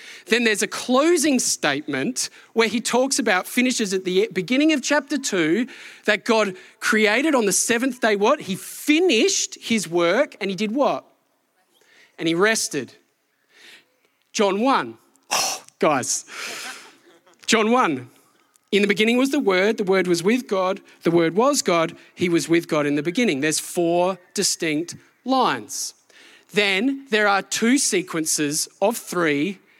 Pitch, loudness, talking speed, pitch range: 215 Hz, -21 LUFS, 150 wpm, 180-255 Hz